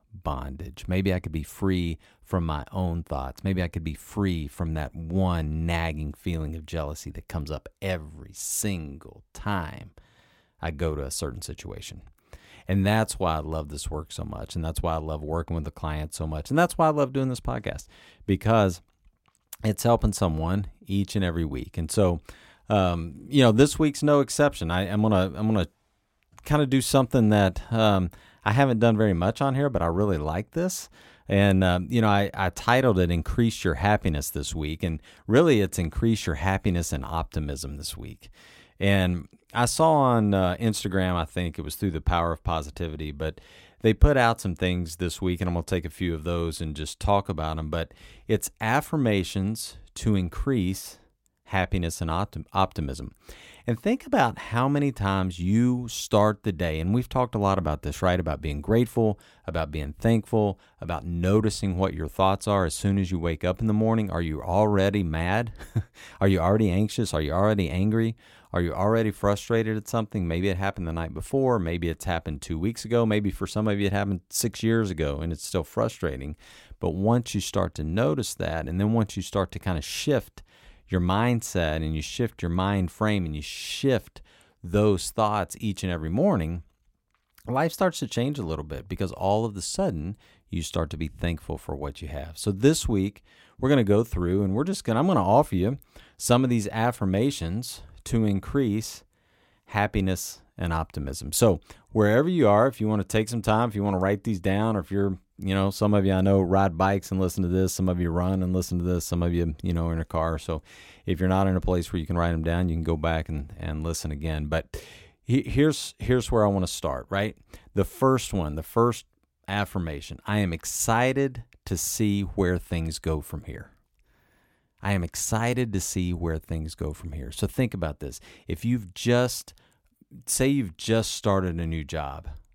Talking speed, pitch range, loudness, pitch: 205 wpm, 80-105 Hz, -26 LUFS, 95 Hz